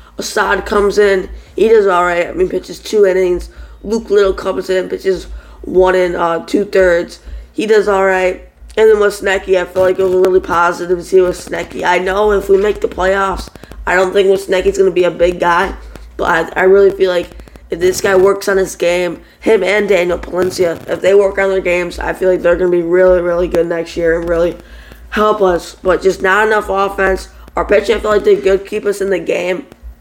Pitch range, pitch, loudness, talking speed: 175-200 Hz, 185 Hz, -13 LUFS, 230 wpm